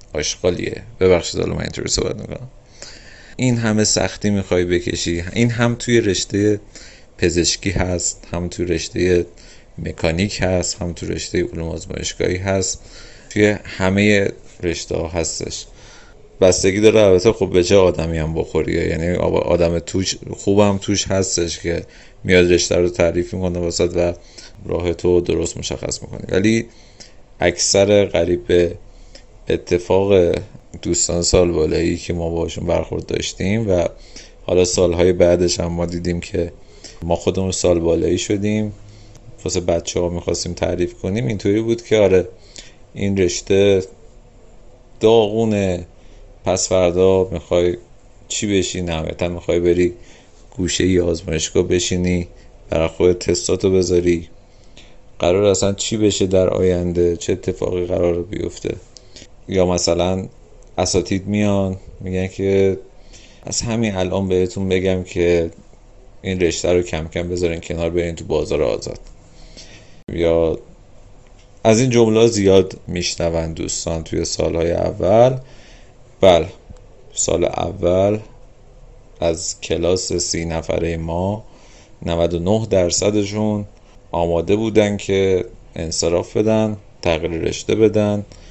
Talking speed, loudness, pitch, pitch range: 120 wpm, -18 LUFS, 95 Hz, 85-105 Hz